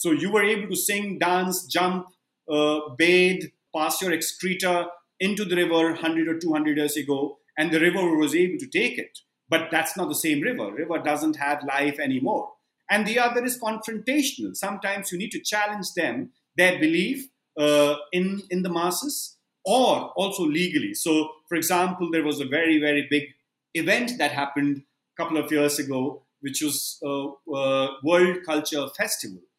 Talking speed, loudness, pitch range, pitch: 175 wpm, -24 LUFS, 150-205 Hz, 170 Hz